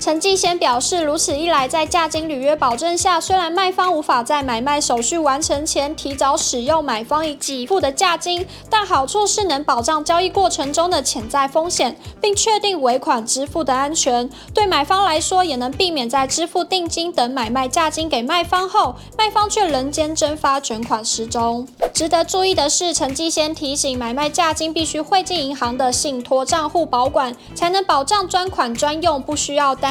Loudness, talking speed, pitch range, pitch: -18 LUFS, 290 characters per minute, 275-345 Hz, 310 Hz